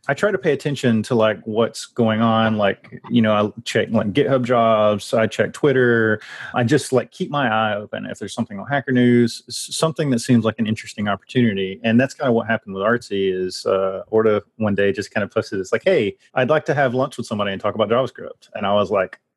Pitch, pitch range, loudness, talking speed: 115 Hz, 105-125 Hz, -20 LUFS, 235 wpm